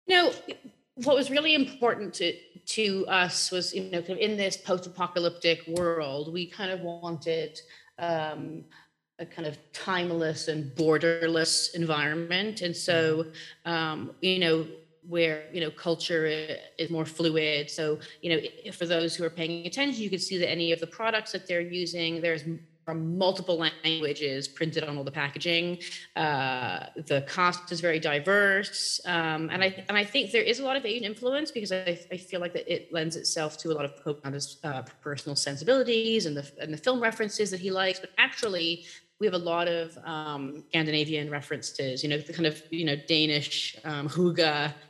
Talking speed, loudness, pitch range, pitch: 180 wpm, -28 LUFS, 155-185 Hz, 165 Hz